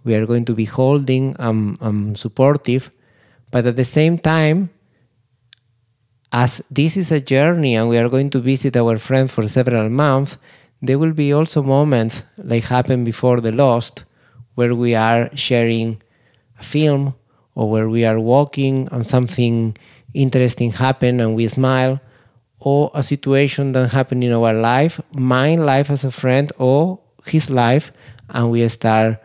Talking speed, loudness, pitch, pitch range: 160 wpm, -17 LUFS, 125 Hz, 115-135 Hz